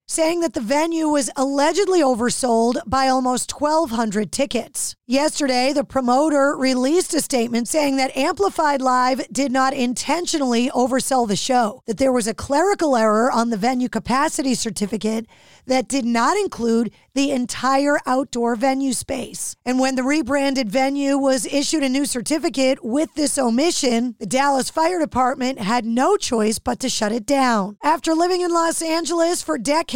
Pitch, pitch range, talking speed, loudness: 265 Hz, 245-295 Hz, 160 wpm, -20 LUFS